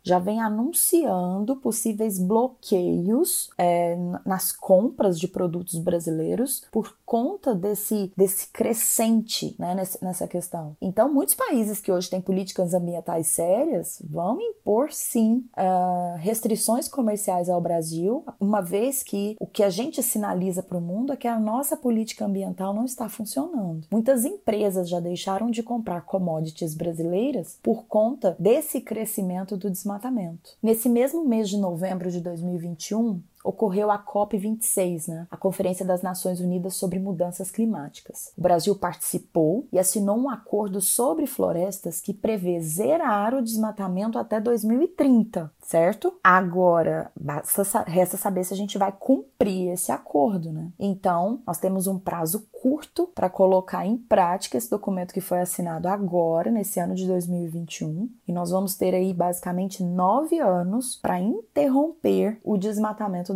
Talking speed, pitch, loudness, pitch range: 145 wpm, 195 Hz, -24 LUFS, 180-225 Hz